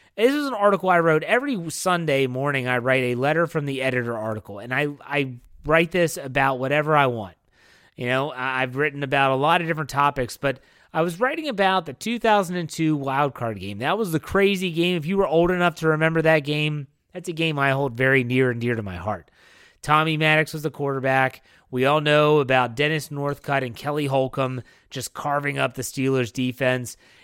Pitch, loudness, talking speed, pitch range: 145 Hz, -22 LUFS, 205 wpm, 130-160 Hz